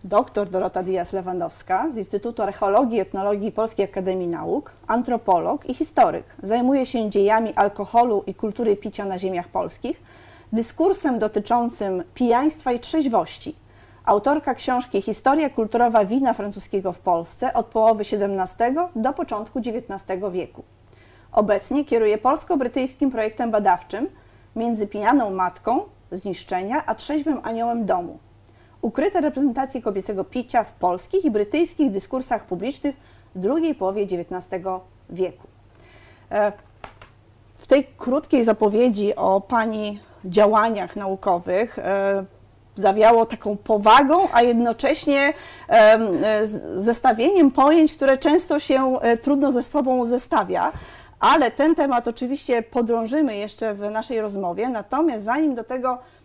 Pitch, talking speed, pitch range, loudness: 225 Hz, 115 wpm, 200-265 Hz, -21 LUFS